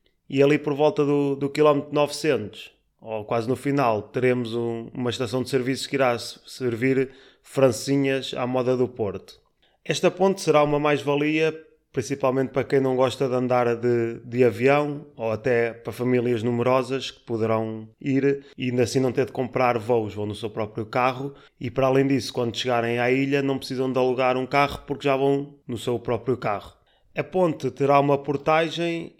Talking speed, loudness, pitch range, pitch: 180 wpm, -24 LUFS, 120-140 Hz, 130 Hz